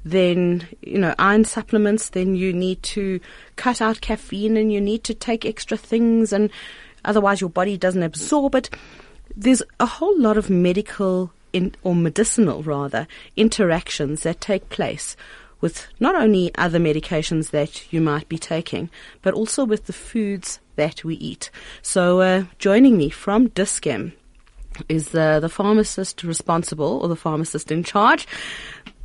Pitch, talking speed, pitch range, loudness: 185 Hz, 155 wpm, 165-215 Hz, -20 LUFS